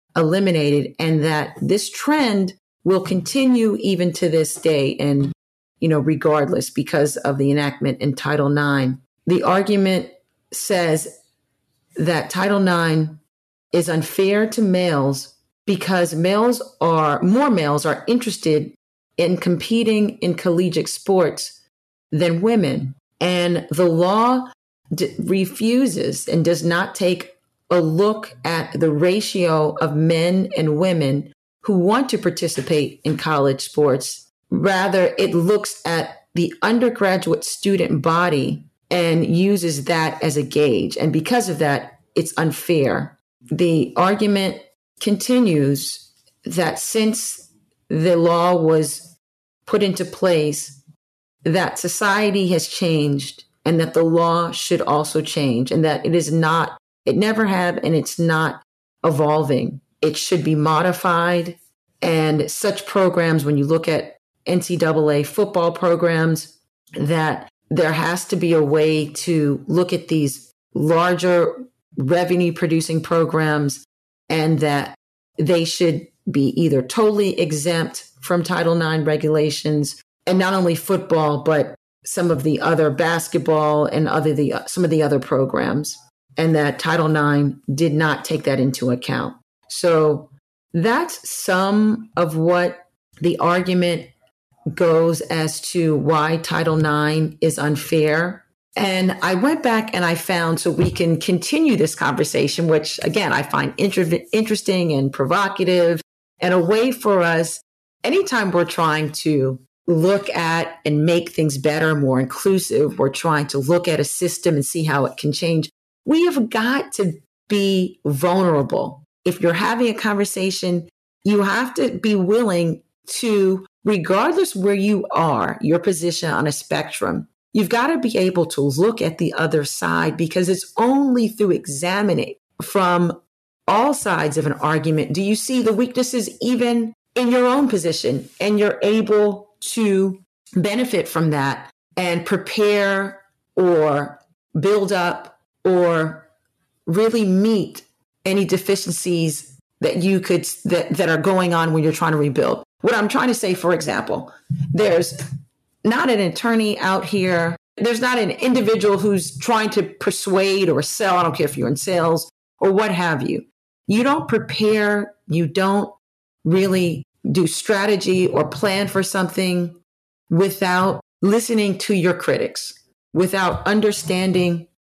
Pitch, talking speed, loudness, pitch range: 170 Hz, 140 wpm, -19 LUFS, 155-195 Hz